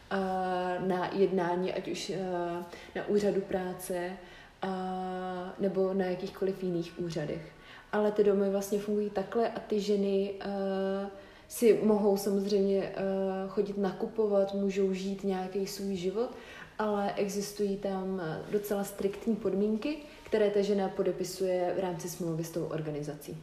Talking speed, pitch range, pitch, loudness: 120 wpm, 185-200 Hz, 195 Hz, -32 LUFS